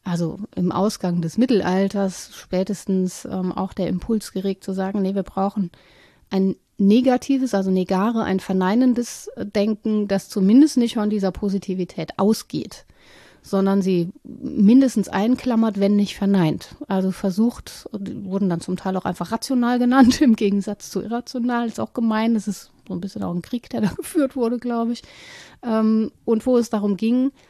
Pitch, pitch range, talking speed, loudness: 205 Hz, 190-235 Hz, 165 wpm, -21 LUFS